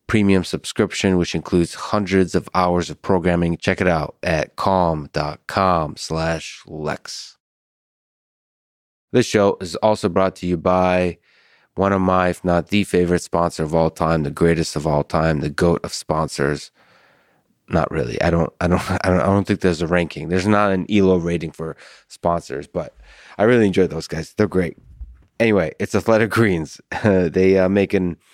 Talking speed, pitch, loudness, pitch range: 170 wpm, 90 Hz, -19 LUFS, 80-95 Hz